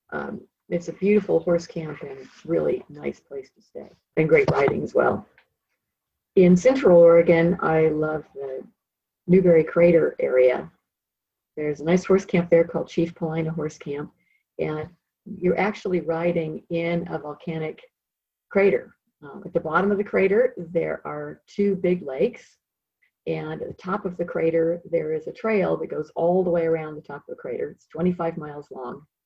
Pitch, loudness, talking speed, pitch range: 170 Hz, -22 LUFS, 170 wpm, 160-195 Hz